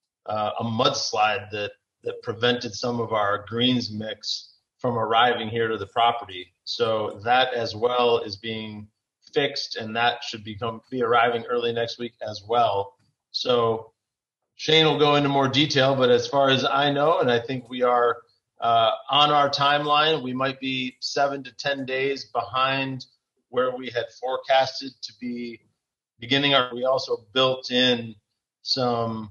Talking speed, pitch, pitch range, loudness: 160 wpm, 120 Hz, 115-135 Hz, -23 LUFS